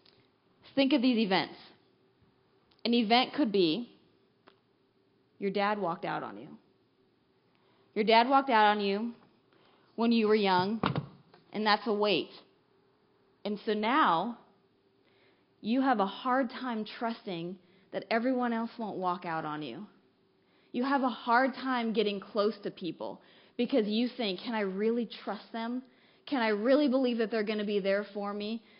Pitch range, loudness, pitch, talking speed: 200-240 Hz, -30 LUFS, 220 Hz, 155 wpm